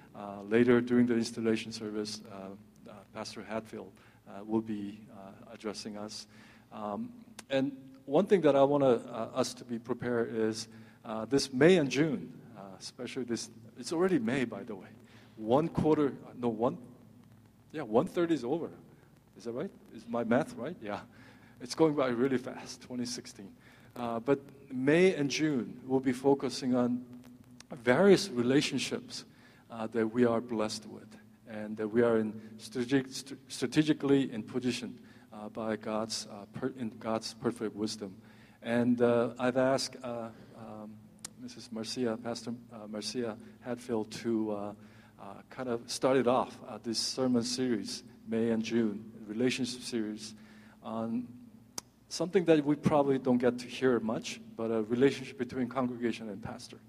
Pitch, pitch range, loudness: 120 Hz, 110-130 Hz, -32 LUFS